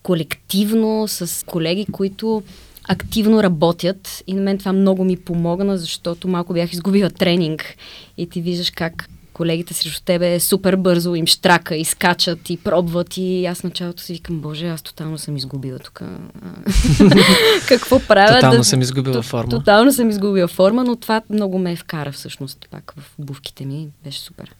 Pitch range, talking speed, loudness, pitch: 165-195 Hz, 165 wpm, -17 LUFS, 175 Hz